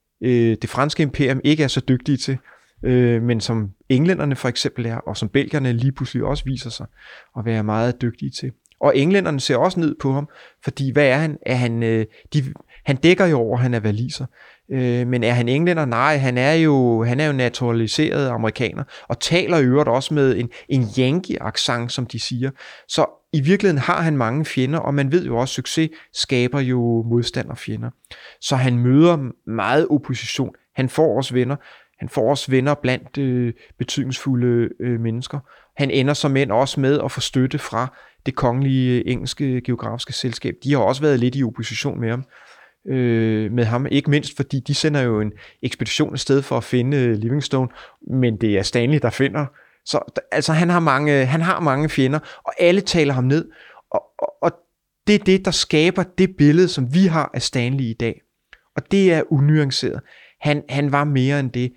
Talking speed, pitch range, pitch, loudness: 195 wpm, 120-150 Hz, 135 Hz, -19 LUFS